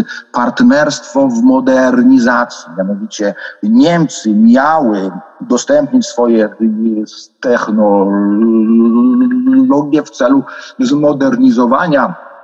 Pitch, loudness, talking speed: 140 Hz, -11 LUFS, 65 wpm